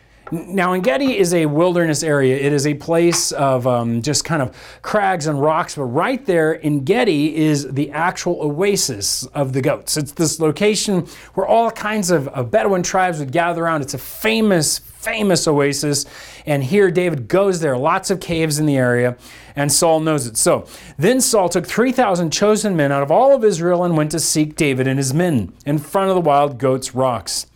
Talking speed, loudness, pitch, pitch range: 195 wpm, -17 LUFS, 160 Hz, 140-185 Hz